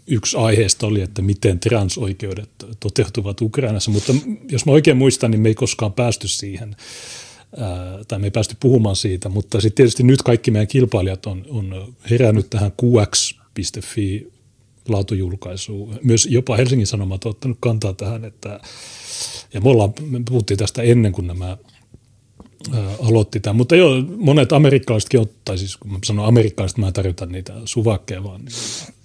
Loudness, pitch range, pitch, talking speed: -18 LUFS, 100-120 Hz, 110 Hz, 155 wpm